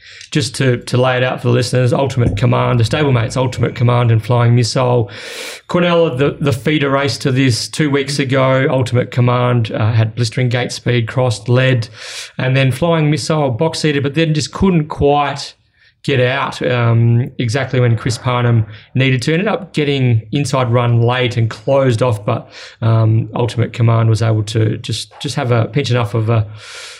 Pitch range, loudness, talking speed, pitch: 120-140 Hz, -15 LUFS, 180 wpm, 125 Hz